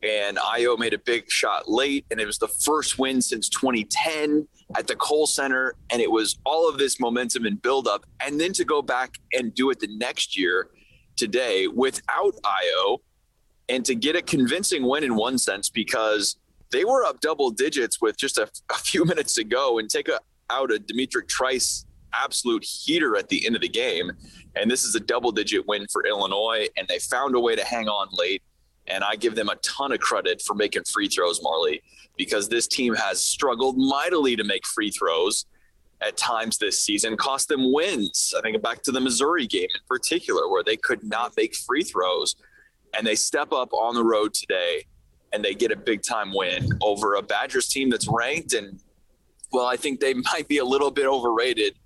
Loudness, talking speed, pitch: -23 LUFS, 200 wpm, 360 Hz